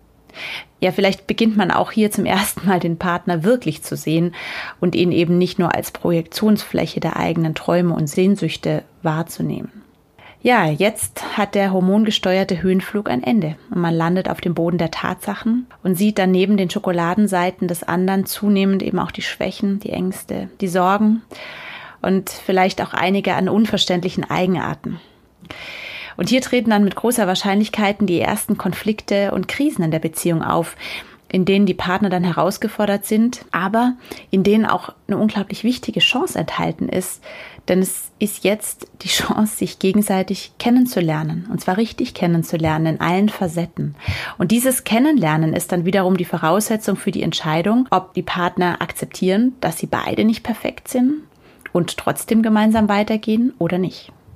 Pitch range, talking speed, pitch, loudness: 175-215 Hz, 160 wpm, 195 Hz, -19 LUFS